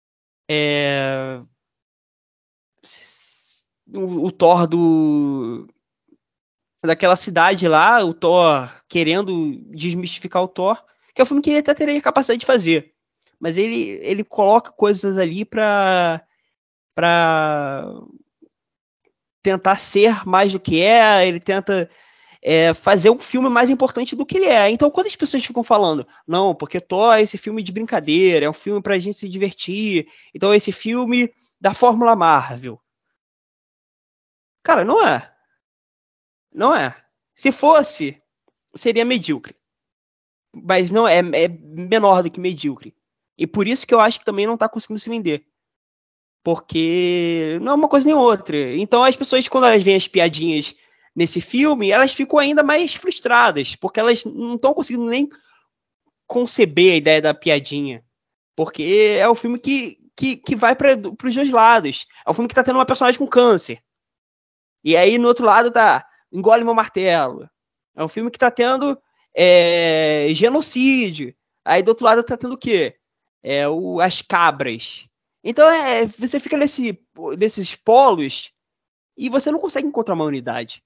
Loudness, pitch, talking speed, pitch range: -17 LUFS, 210 Hz, 155 wpm, 170-250 Hz